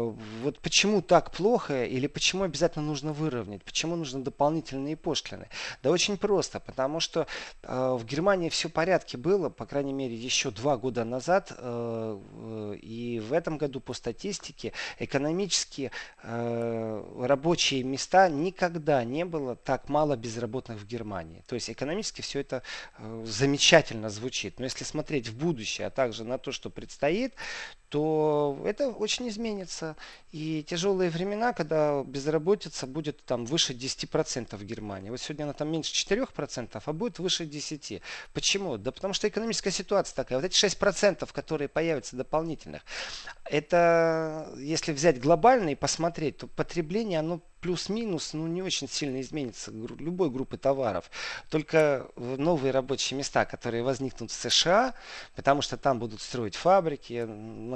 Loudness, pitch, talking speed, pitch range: -29 LUFS, 145 Hz, 145 wpm, 125-170 Hz